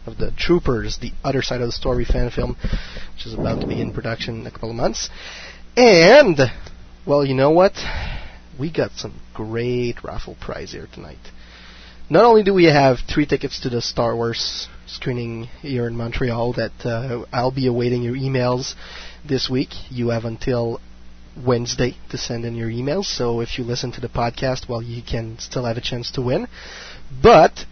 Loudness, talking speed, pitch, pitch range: -19 LUFS, 185 wpm, 120 Hz, 115-130 Hz